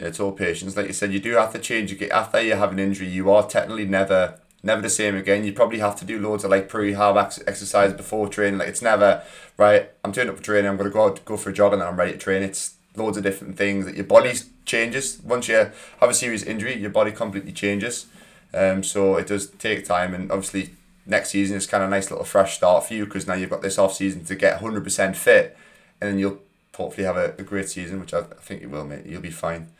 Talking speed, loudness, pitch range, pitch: 270 wpm, -22 LUFS, 95-105 Hz, 100 Hz